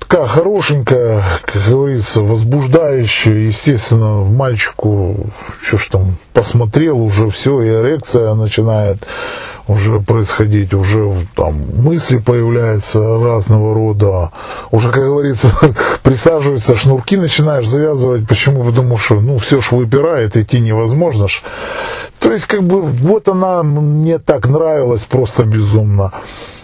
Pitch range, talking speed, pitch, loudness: 110-140 Hz, 115 wpm, 120 Hz, -12 LUFS